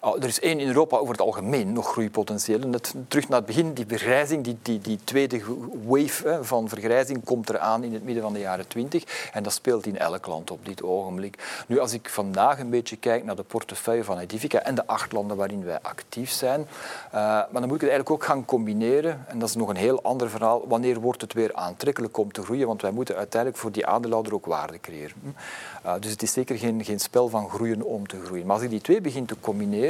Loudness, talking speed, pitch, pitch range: -26 LUFS, 240 wpm, 115 Hz, 105-125 Hz